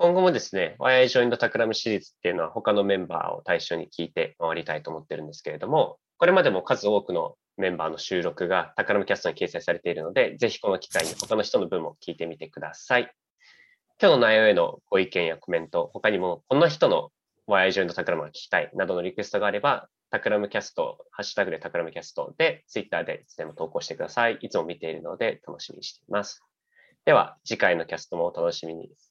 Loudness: -25 LUFS